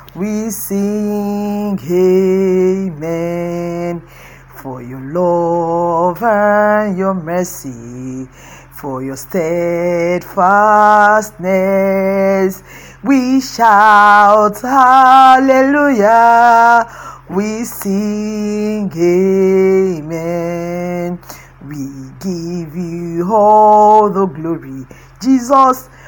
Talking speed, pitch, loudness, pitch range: 60 wpm, 190 Hz, -12 LUFS, 170-210 Hz